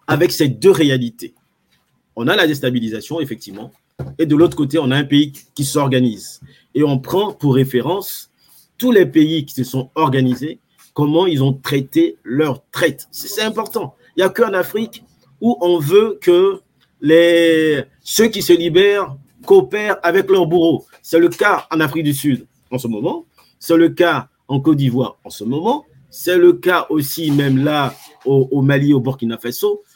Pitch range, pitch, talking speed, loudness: 135-180 Hz, 155 Hz, 175 wpm, -16 LUFS